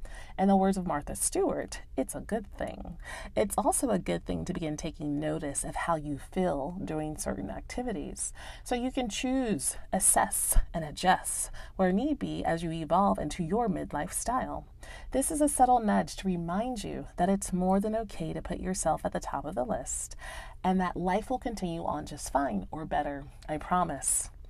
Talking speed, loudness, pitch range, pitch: 190 wpm, -31 LUFS, 155-210 Hz, 180 Hz